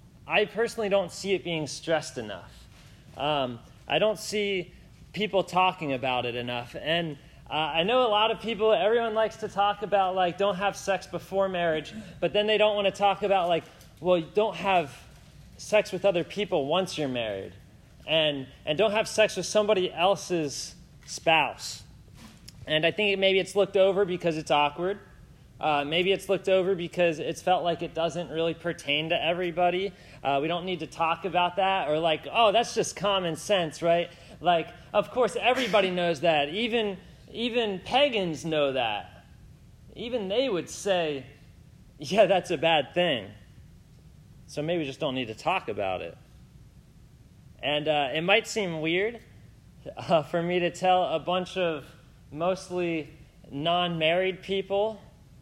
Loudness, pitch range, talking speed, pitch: -27 LUFS, 160-200 Hz, 165 wpm, 180 Hz